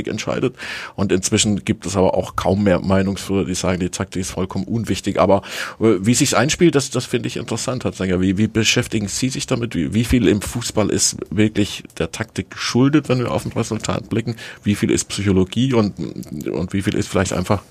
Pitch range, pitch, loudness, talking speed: 95-120 Hz, 105 Hz, -19 LUFS, 205 wpm